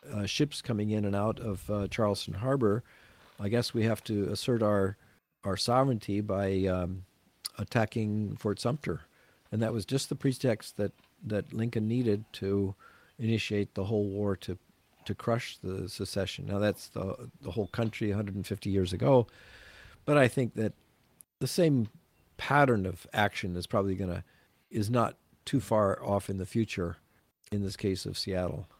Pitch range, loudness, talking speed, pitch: 100-115 Hz, -31 LUFS, 165 wpm, 105 Hz